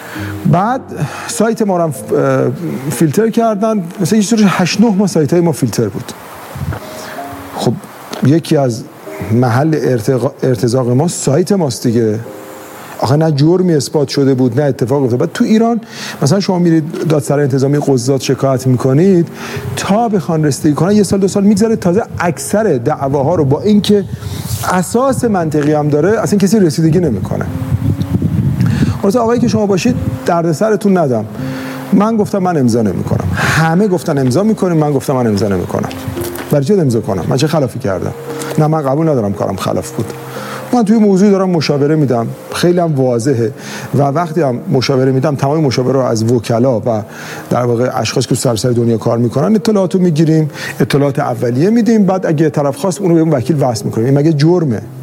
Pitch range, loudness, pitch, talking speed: 130-185 Hz, -13 LUFS, 150 Hz, 165 wpm